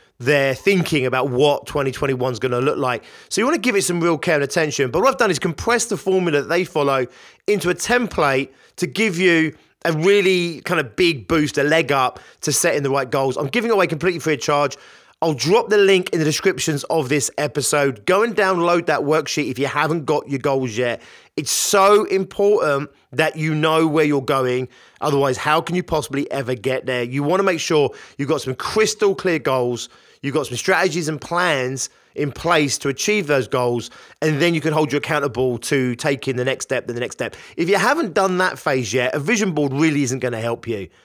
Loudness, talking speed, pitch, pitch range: -19 LUFS, 225 wpm, 155 Hz, 135-180 Hz